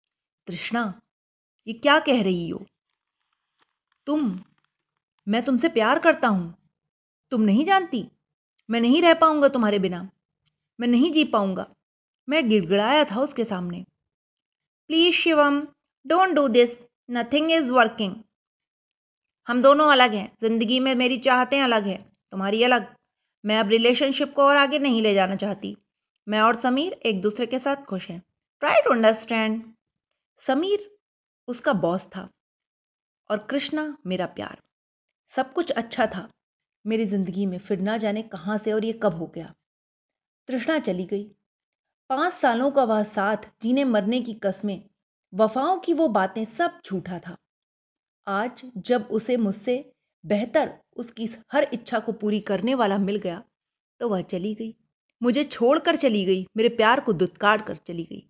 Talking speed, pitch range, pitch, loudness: 150 wpm, 205-270 Hz, 230 Hz, -23 LUFS